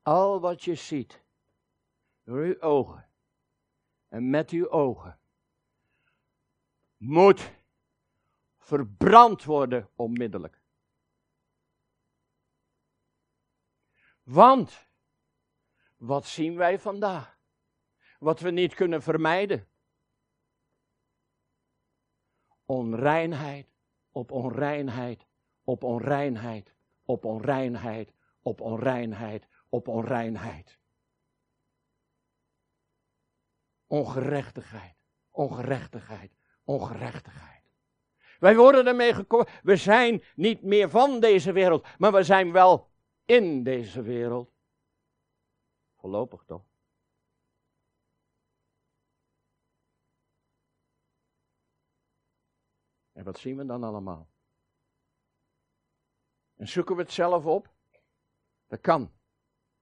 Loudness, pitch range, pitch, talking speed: -24 LUFS, 120-180 Hz, 140 Hz, 75 wpm